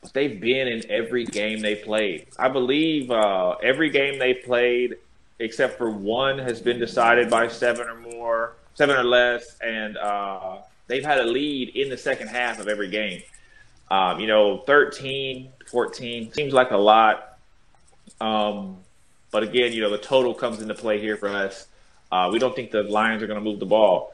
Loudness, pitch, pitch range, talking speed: -22 LUFS, 115 Hz, 105-125 Hz, 185 wpm